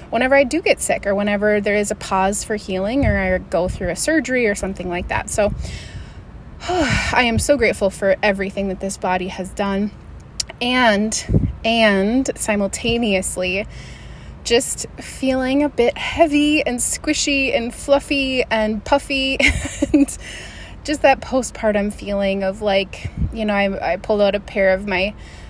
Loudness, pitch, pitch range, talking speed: -18 LUFS, 215 Hz, 195-265 Hz, 160 wpm